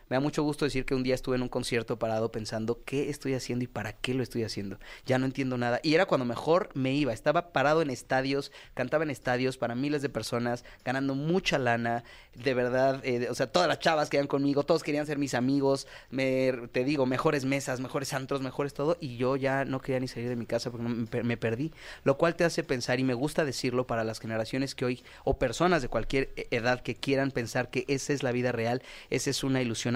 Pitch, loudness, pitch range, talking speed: 130 Hz, -30 LUFS, 120-140 Hz, 230 wpm